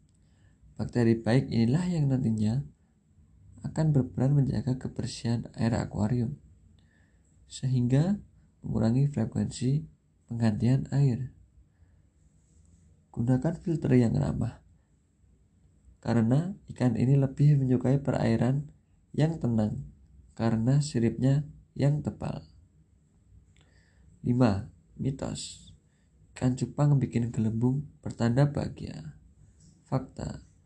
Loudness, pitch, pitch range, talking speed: -28 LUFS, 115 Hz, 85-130 Hz, 80 wpm